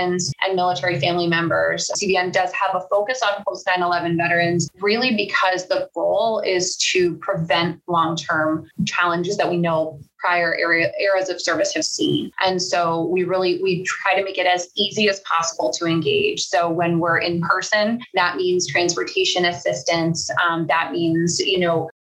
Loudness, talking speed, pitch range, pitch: -20 LUFS, 165 wpm, 170-195 Hz, 180 Hz